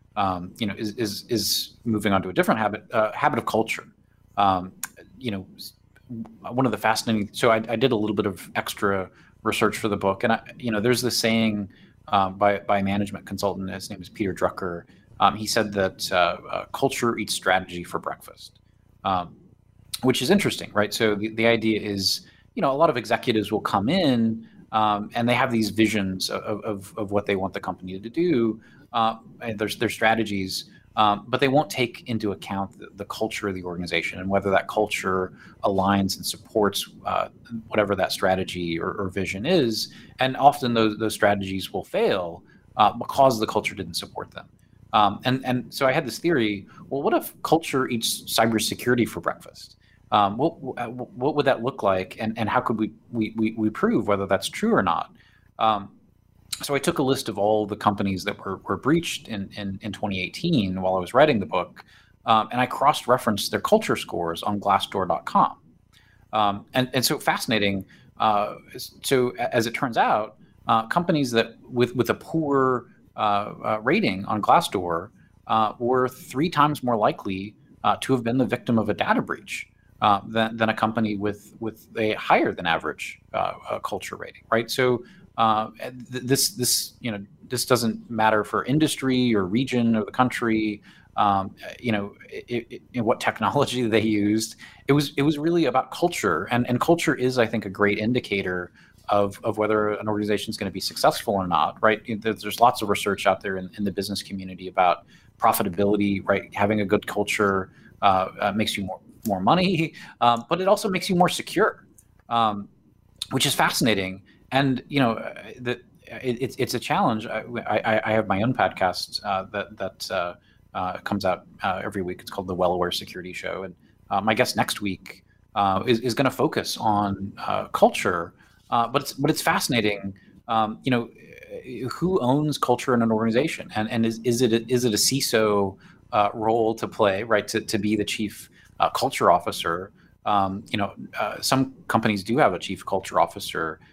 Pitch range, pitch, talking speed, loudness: 100-125 Hz, 110 Hz, 190 wpm, -24 LUFS